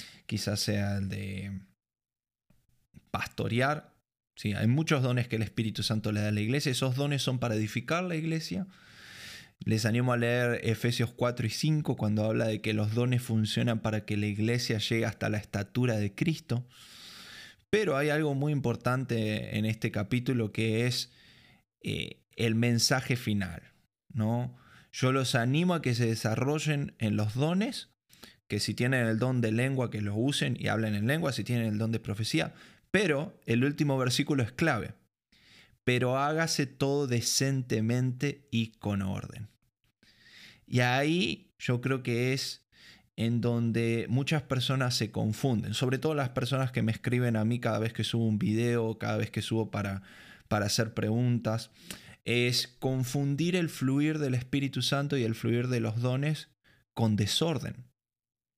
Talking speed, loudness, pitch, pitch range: 160 wpm, -30 LUFS, 120 Hz, 110-135 Hz